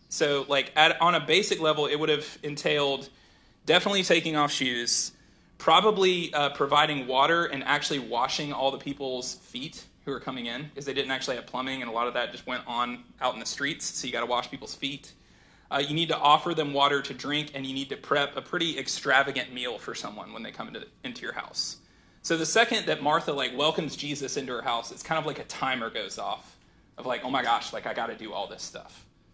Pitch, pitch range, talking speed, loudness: 140 Hz, 135-155 Hz, 235 wpm, -27 LUFS